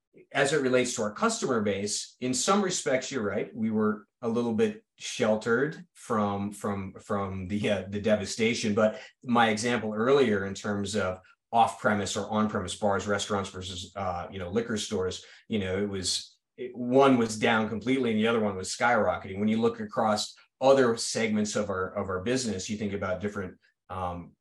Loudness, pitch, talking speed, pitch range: -28 LUFS, 105 Hz, 185 wpm, 100-120 Hz